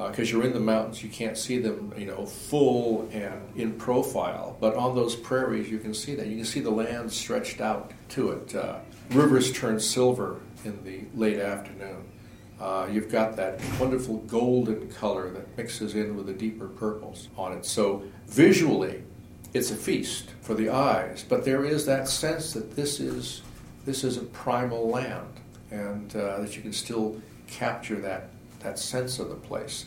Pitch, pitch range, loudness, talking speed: 110 Hz, 105-125 Hz, -28 LUFS, 185 wpm